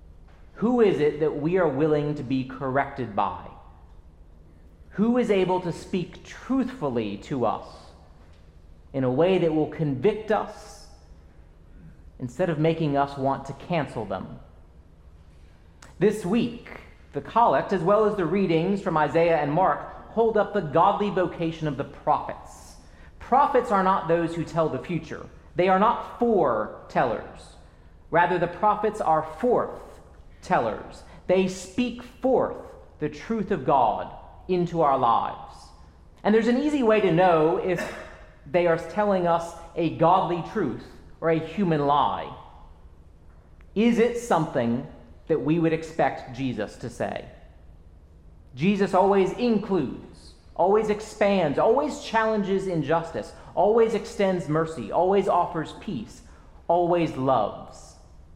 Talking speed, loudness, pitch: 130 wpm, -24 LUFS, 160 Hz